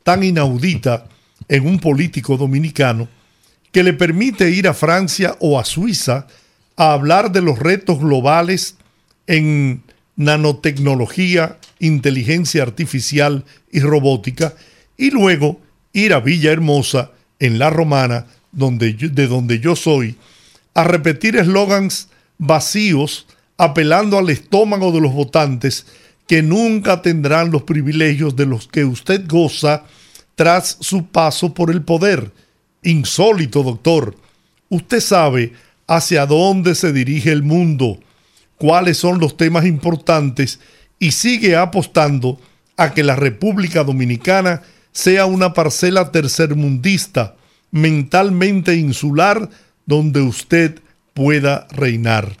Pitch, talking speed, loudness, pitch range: 160 Hz, 115 wpm, -15 LUFS, 140-180 Hz